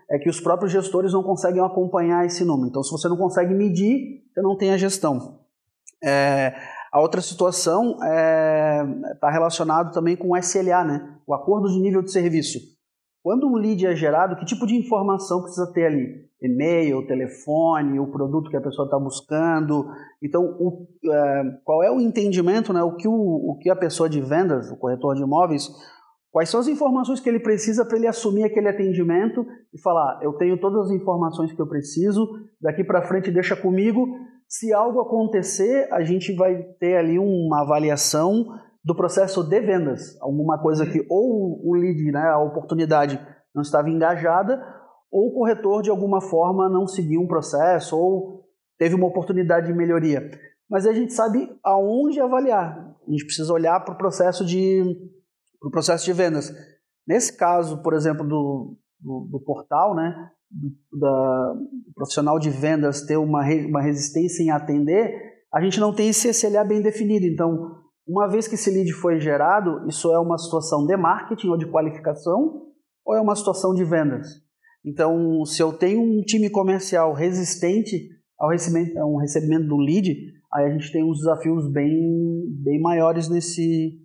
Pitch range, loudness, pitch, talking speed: 155-195 Hz, -21 LUFS, 175 Hz, 175 wpm